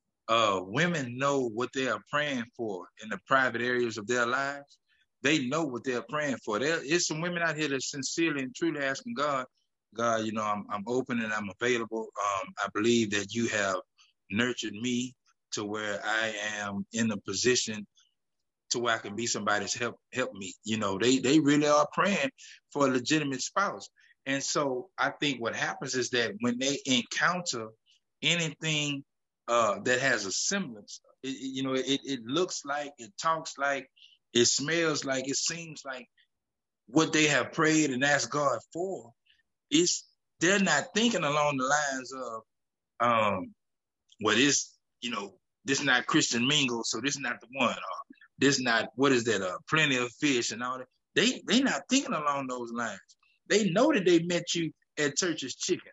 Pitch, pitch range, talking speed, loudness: 135 Hz, 120-155 Hz, 190 wpm, -29 LUFS